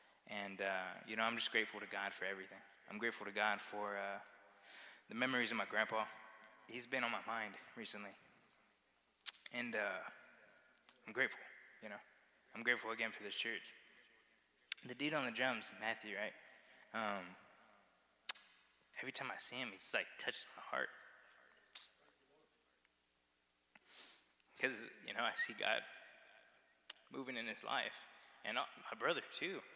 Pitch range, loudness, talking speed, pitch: 100-115 Hz, -42 LUFS, 145 wpm, 110 Hz